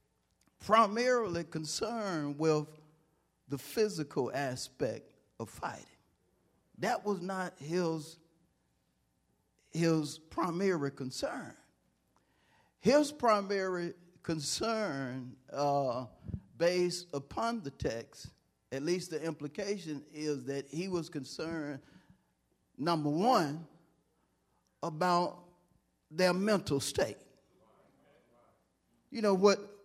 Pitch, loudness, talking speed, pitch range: 165 Hz, -34 LUFS, 80 wpm, 145-185 Hz